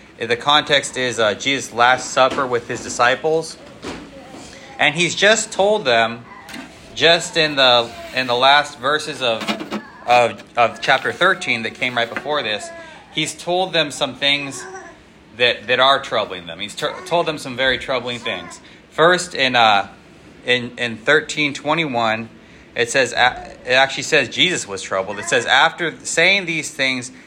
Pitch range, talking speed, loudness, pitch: 120-155 Hz, 155 wpm, -17 LUFS, 130 Hz